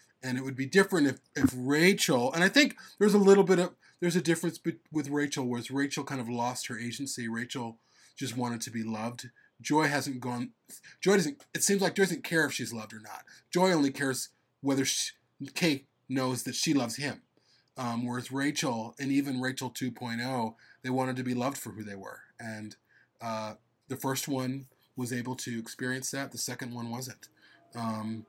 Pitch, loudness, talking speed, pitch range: 130 Hz, -30 LUFS, 195 wpm, 120-145 Hz